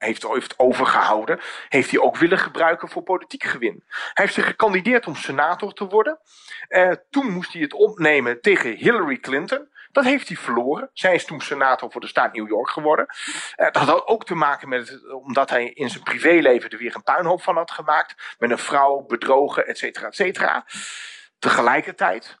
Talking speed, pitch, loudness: 180 wpm, 185 Hz, -20 LUFS